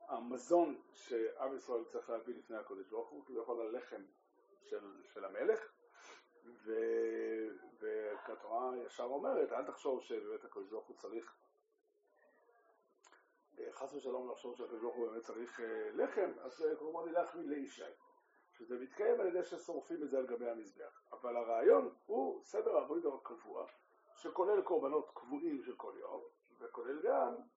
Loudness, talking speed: -41 LUFS, 135 wpm